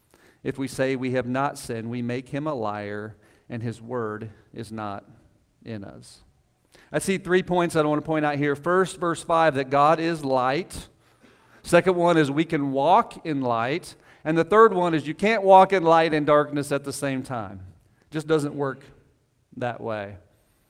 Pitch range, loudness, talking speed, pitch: 115-160 Hz, -23 LUFS, 190 wpm, 140 Hz